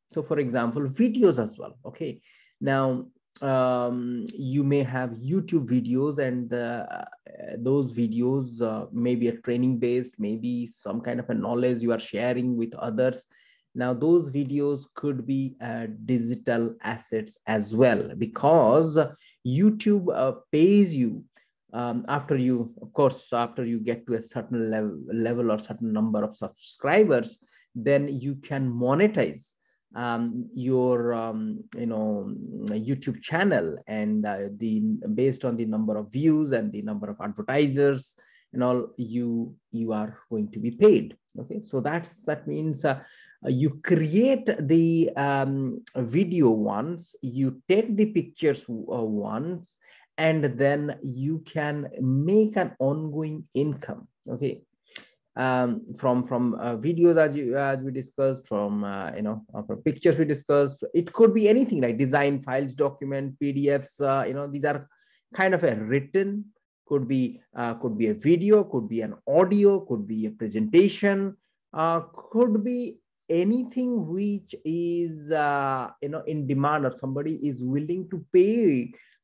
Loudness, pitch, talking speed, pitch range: -25 LUFS, 135 Hz, 150 wpm, 120-160 Hz